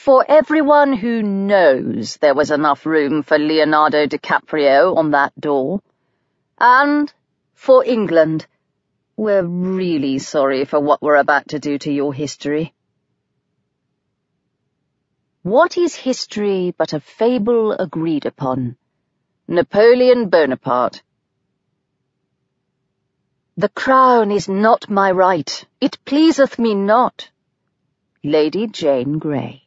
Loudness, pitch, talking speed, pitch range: -16 LUFS, 175 Hz, 105 wpm, 150-230 Hz